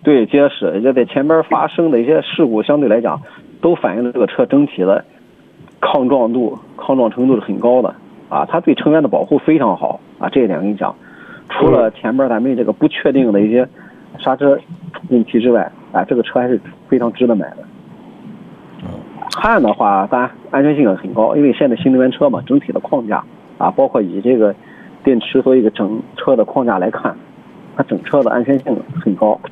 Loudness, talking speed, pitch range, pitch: -14 LUFS, 290 characters per minute, 120-150 Hz, 130 Hz